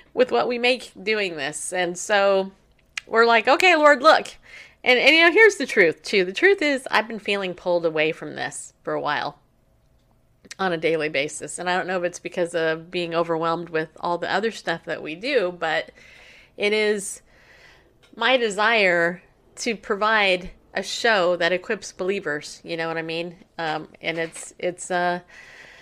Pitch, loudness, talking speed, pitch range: 180 Hz, -21 LUFS, 180 wpm, 165-220 Hz